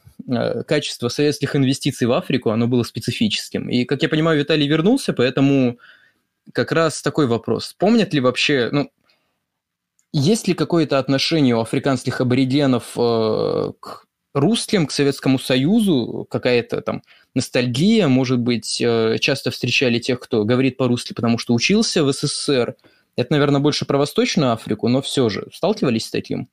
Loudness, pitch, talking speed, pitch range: -19 LUFS, 135 Hz, 145 wpm, 125-150 Hz